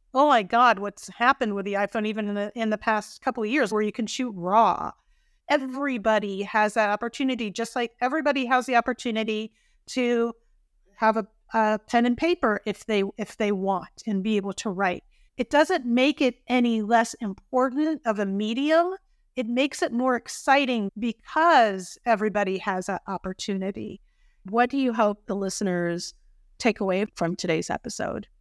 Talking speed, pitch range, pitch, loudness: 170 wpm, 205-255 Hz, 225 Hz, -25 LUFS